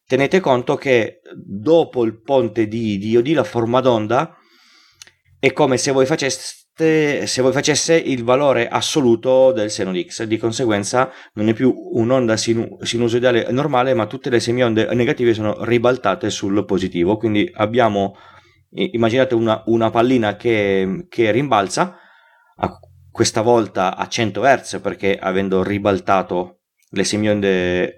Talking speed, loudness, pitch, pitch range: 135 wpm, -18 LUFS, 115 Hz, 105-130 Hz